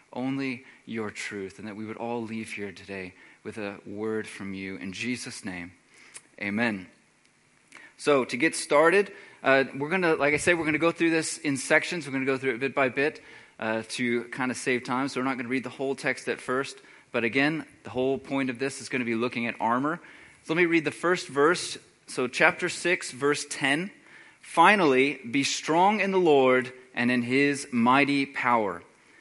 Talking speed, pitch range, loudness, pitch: 210 wpm, 120-145 Hz, -26 LUFS, 130 Hz